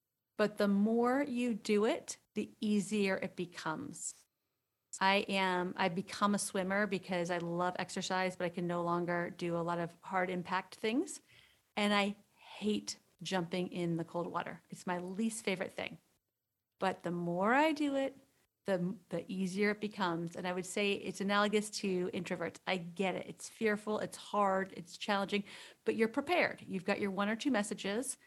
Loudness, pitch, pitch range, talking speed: -36 LUFS, 190 Hz, 180-210 Hz, 175 wpm